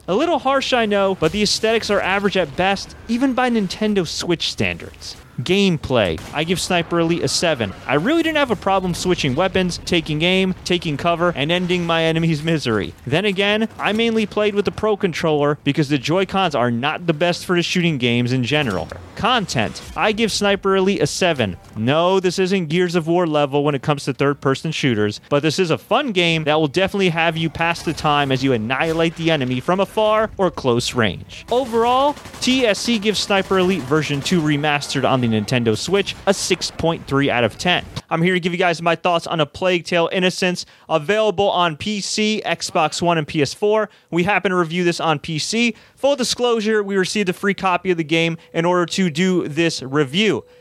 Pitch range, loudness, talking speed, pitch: 150-195 Hz, -18 LUFS, 200 wpm, 175 Hz